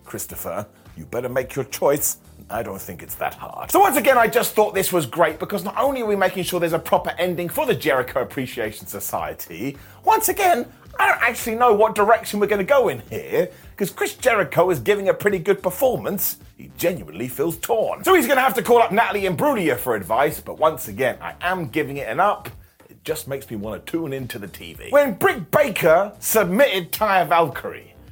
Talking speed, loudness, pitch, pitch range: 215 wpm, -20 LUFS, 200 Hz, 170-245 Hz